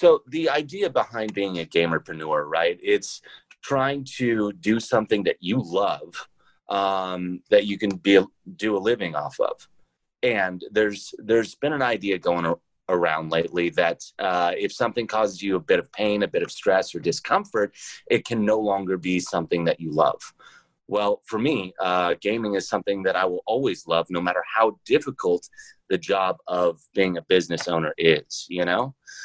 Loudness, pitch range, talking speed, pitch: -24 LUFS, 90-120 Hz, 175 wpm, 100 Hz